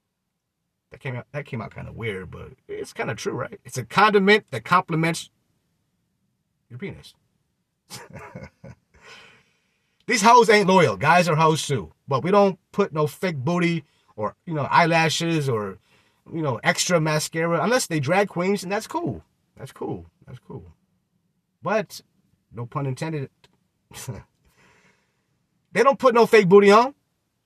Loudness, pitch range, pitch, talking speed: -20 LUFS, 150-205 Hz, 170 Hz, 150 wpm